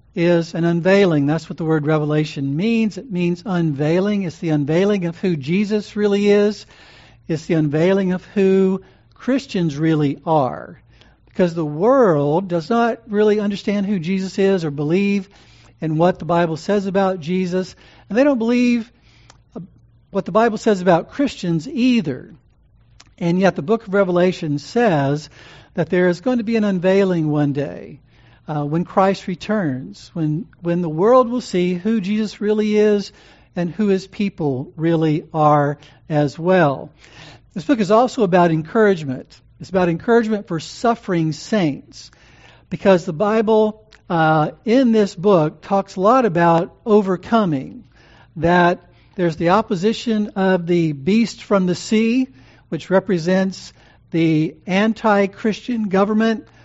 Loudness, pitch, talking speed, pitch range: -18 LUFS, 180 Hz, 145 wpm, 155-210 Hz